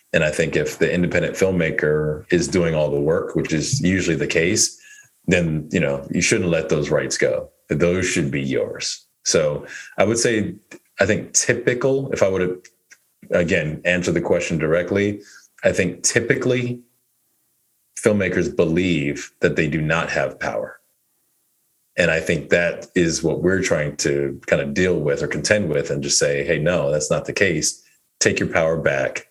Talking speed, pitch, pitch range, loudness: 175 wpm, 90 Hz, 75-125 Hz, -20 LUFS